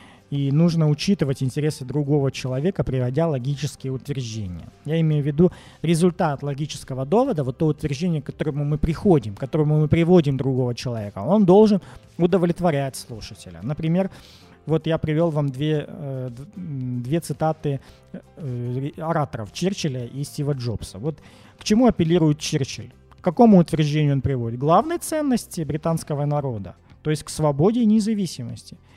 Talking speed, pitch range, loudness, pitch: 140 wpm, 130-165 Hz, -22 LUFS, 150 Hz